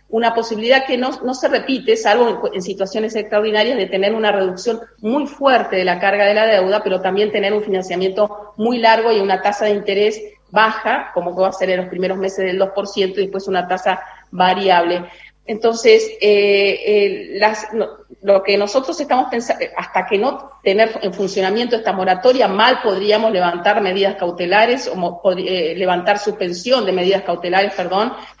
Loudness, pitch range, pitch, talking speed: -16 LUFS, 190-225 Hz, 205 Hz, 175 wpm